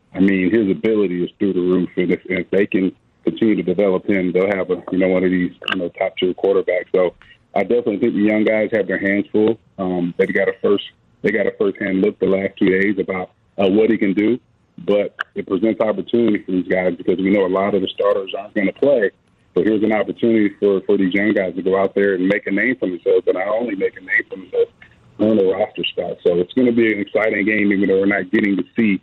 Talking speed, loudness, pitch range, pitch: 260 wpm, -18 LUFS, 95-110 Hz, 100 Hz